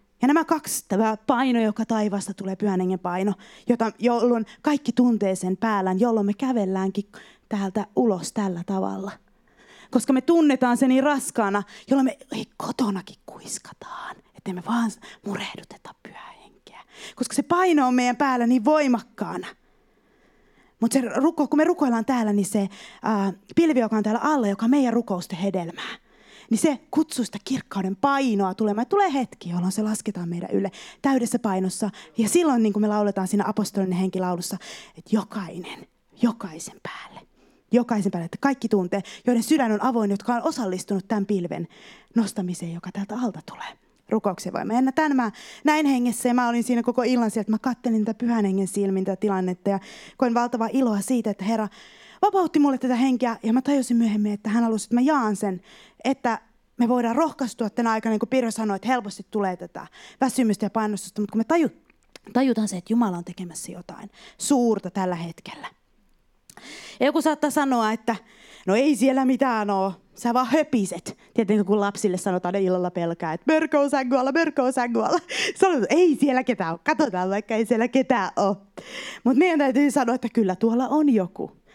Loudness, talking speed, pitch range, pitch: -23 LUFS, 175 wpm, 200-255 Hz, 225 Hz